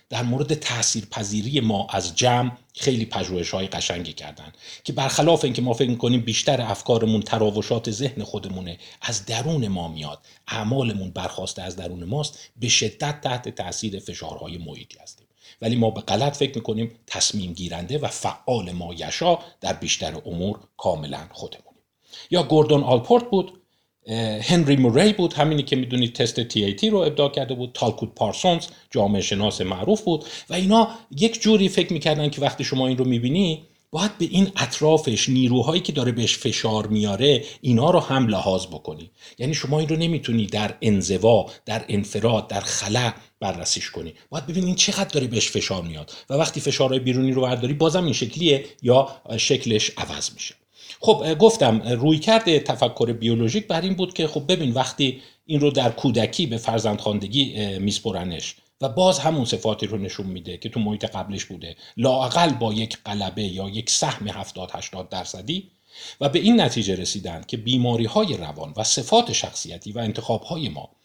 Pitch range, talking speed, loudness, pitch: 105-150 Hz, 165 wpm, -22 LUFS, 120 Hz